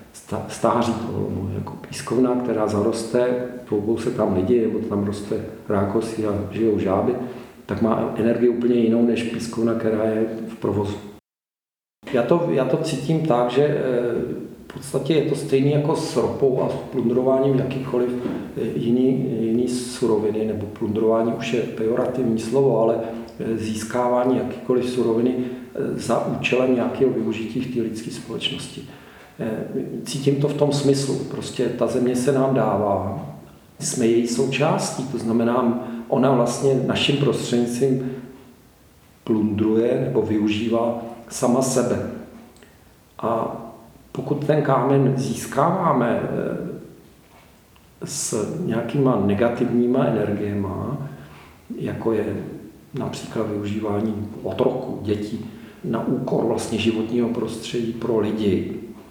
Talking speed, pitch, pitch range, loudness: 115 wpm, 120 Hz, 110-130 Hz, -22 LUFS